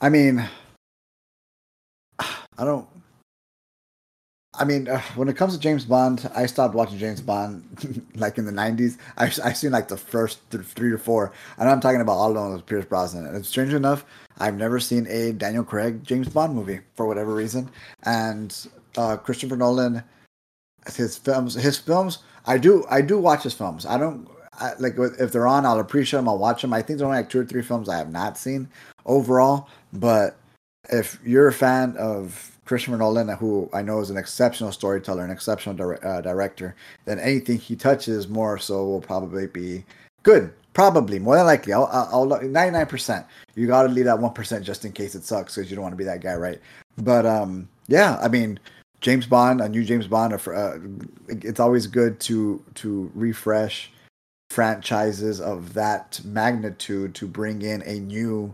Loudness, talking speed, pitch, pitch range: -22 LUFS, 190 wpm, 115 Hz, 105-125 Hz